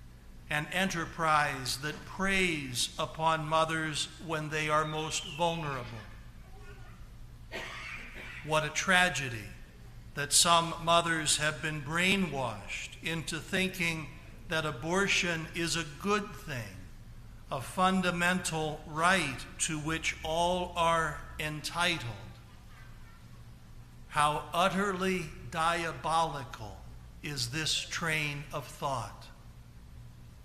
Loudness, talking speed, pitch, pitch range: -31 LUFS, 85 wpm, 155 Hz, 125-170 Hz